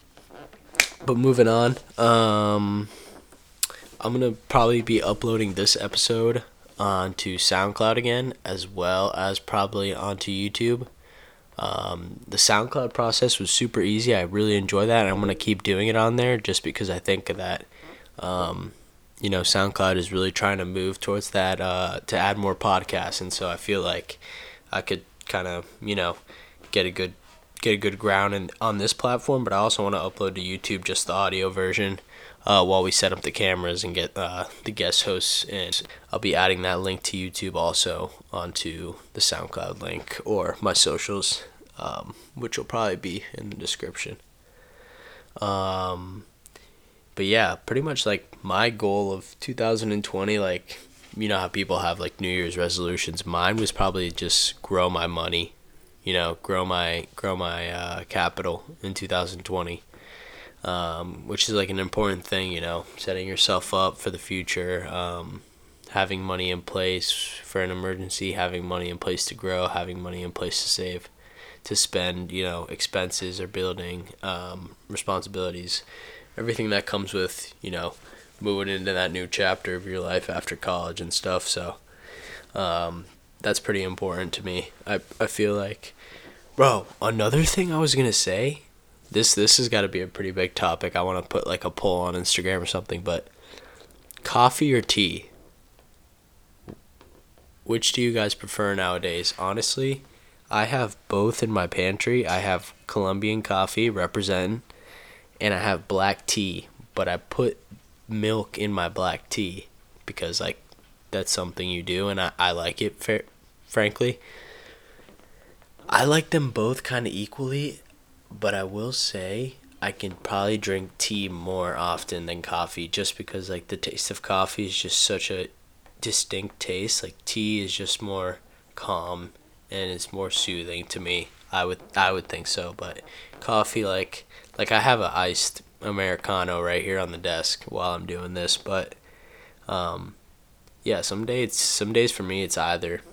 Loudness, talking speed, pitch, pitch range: -25 LUFS, 170 wpm, 95 Hz, 90-105 Hz